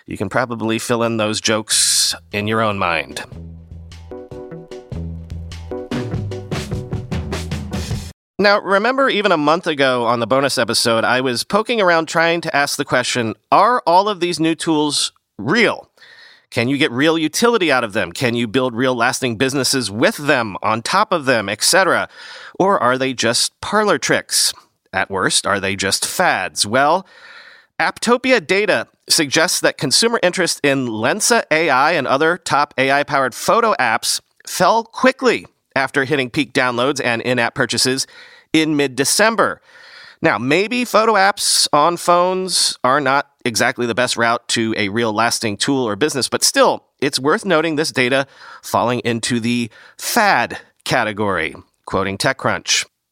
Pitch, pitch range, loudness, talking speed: 130 Hz, 115-170 Hz, -16 LUFS, 150 wpm